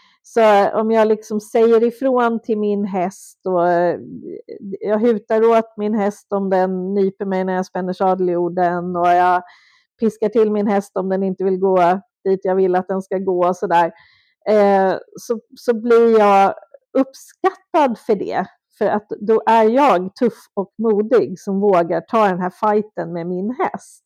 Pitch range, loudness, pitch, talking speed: 185-225 Hz, -17 LUFS, 205 Hz, 170 wpm